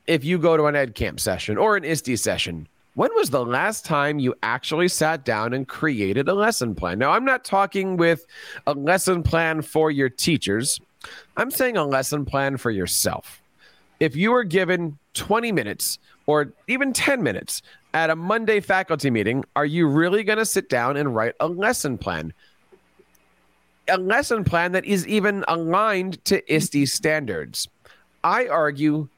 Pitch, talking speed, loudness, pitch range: 160 Hz, 170 wpm, -22 LUFS, 140-195 Hz